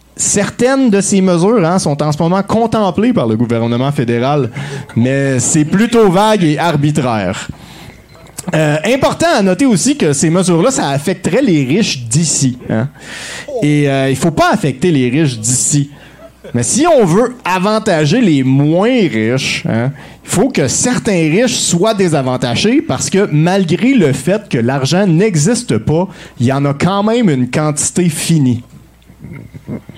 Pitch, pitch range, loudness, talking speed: 160 Hz, 135-200 Hz, -12 LUFS, 155 wpm